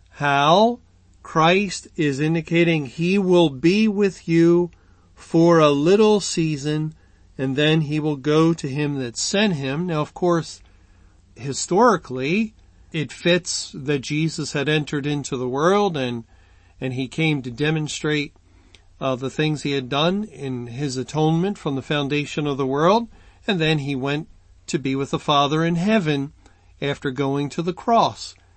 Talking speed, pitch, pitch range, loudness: 155 wpm, 150 Hz, 130-170 Hz, -21 LUFS